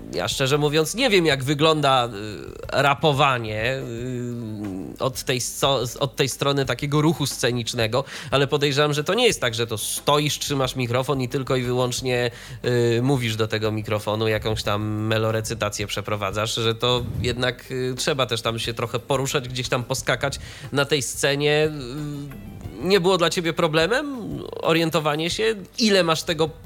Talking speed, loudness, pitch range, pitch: 150 wpm, -22 LUFS, 115-150 Hz, 130 Hz